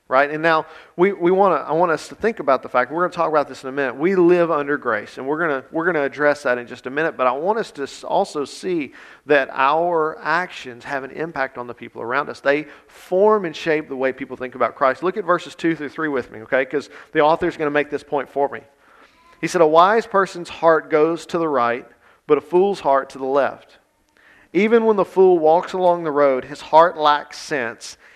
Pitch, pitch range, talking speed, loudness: 155 Hz, 140-175 Hz, 245 wpm, -19 LUFS